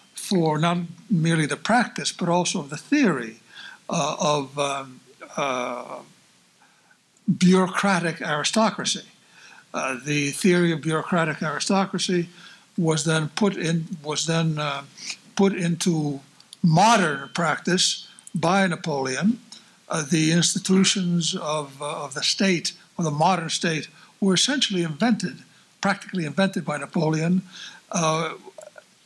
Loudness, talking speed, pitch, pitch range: -23 LUFS, 110 wpm, 175 Hz, 155-195 Hz